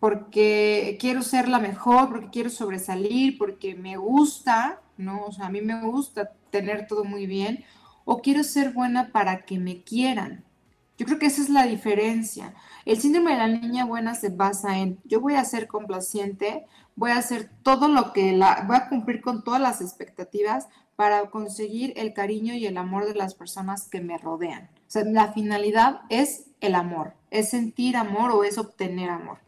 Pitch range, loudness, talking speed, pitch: 200-250 Hz, -24 LUFS, 185 wpm, 220 Hz